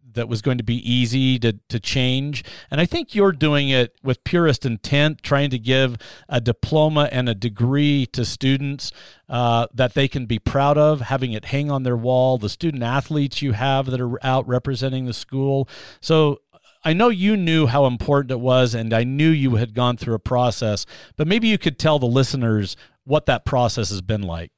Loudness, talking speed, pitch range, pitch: -20 LUFS, 205 wpm, 120-145 Hz, 130 Hz